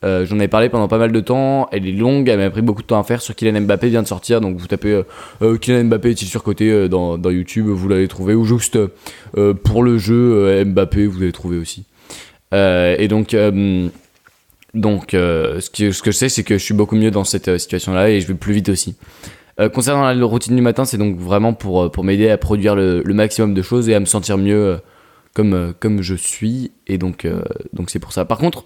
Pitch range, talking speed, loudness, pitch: 95-115 Hz, 250 wpm, -16 LUFS, 105 Hz